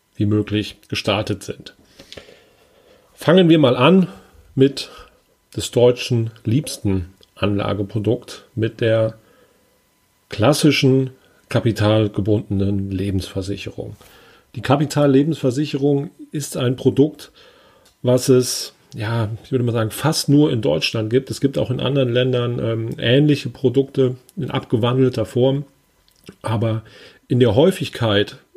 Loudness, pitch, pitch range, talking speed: -19 LUFS, 125 Hz, 110-140 Hz, 105 wpm